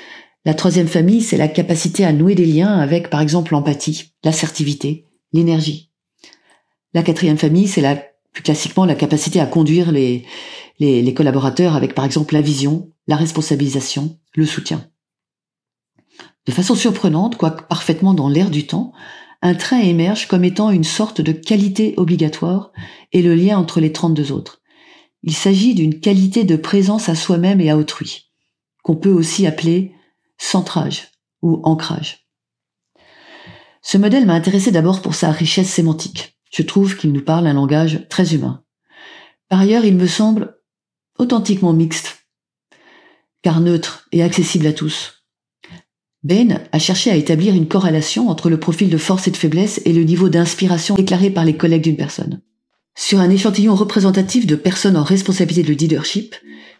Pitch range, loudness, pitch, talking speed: 155-195 Hz, -15 LUFS, 170 Hz, 160 wpm